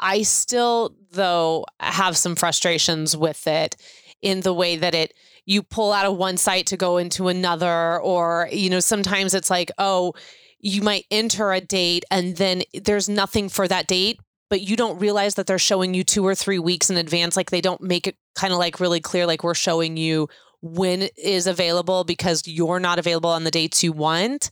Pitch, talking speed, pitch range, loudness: 185 Hz, 205 wpm, 170-195 Hz, -21 LUFS